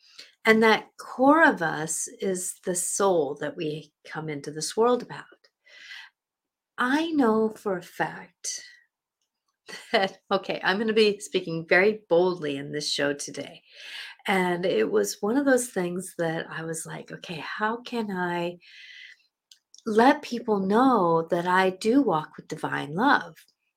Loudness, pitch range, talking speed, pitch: -25 LUFS, 170-230 Hz, 145 wpm, 195 Hz